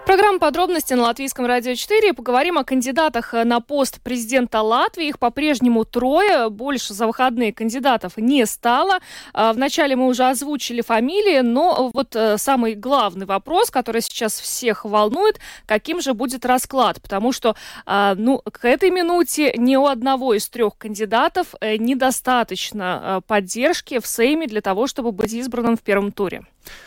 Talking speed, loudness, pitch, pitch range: 145 wpm, -19 LUFS, 250 Hz, 225-280 Hz